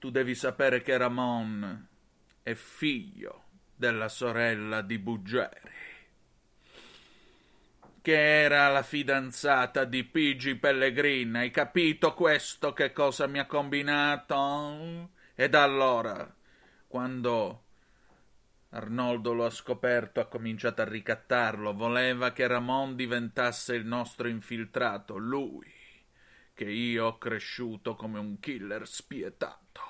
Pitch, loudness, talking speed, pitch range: 125 Hz, -29 LUFS, 110 wpm, 115-140 Hz